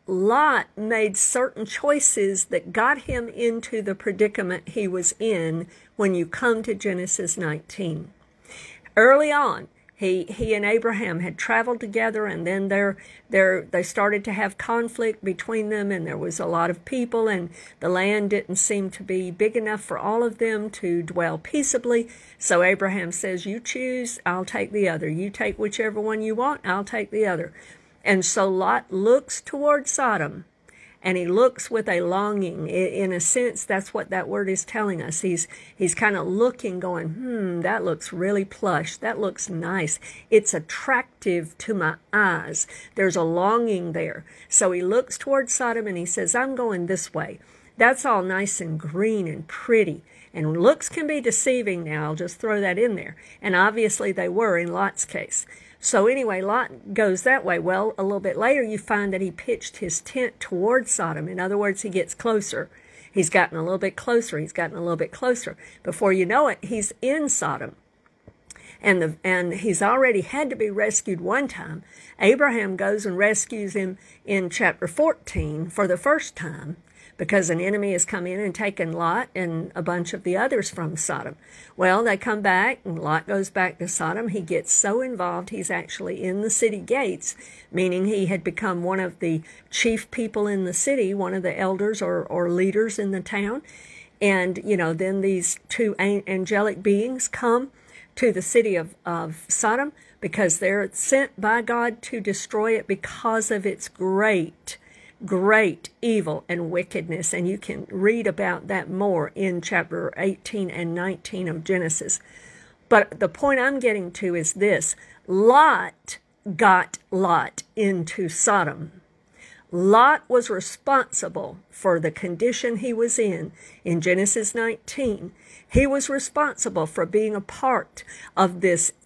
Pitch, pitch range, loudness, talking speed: 195 Hz, 180-225 Hz, -23 LUFS, 170 wpm